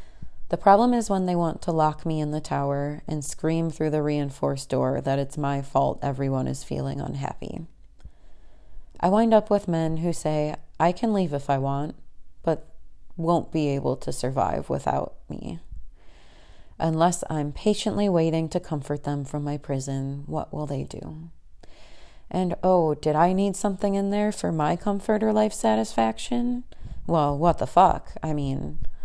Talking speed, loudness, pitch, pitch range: 165 wpm, -25 LUFS, 150 Hz, 135-175 Hz